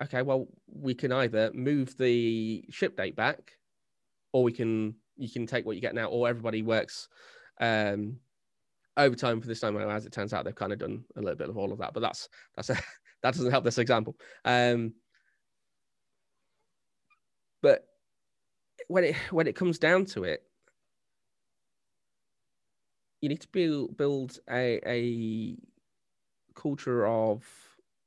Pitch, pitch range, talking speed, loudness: 120 Hz, 115-135 Hz, 155 wpm, -30 LUFS